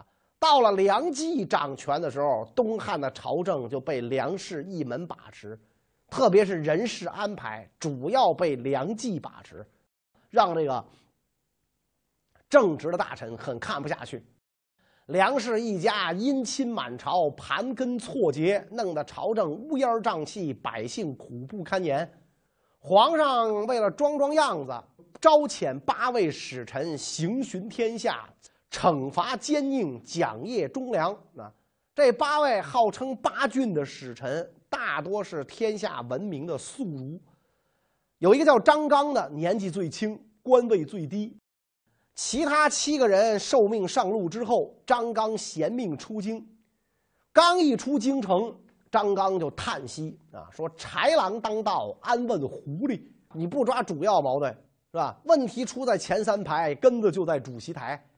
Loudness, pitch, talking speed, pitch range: -26 LUFS, 215 Hz, 205 characters per minute, 160-255 Hz